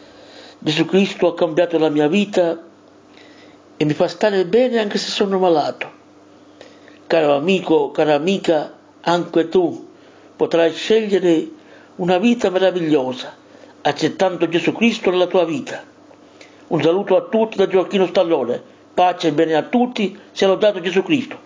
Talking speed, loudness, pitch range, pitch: 135 wpm, -18 LUFS, 165-215 Hz, 185 Hz